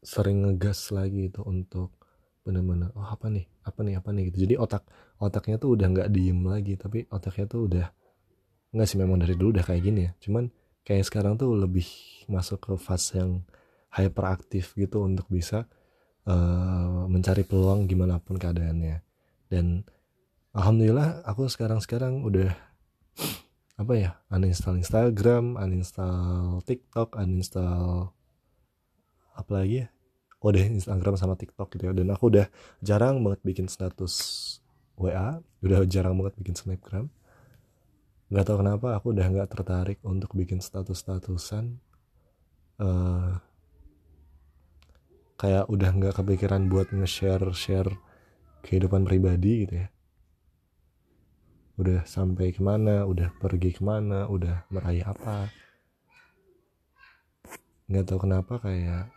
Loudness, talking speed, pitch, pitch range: -27 LUFS, 125 wpm, 95 Hz, 90-105 Hz